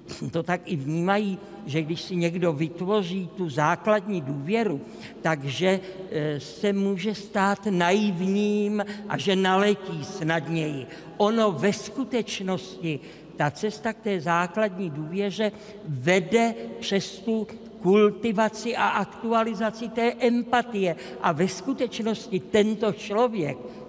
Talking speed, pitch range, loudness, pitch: 110 wpm, 175-215 Hz, -26 LUFS, 195 Hz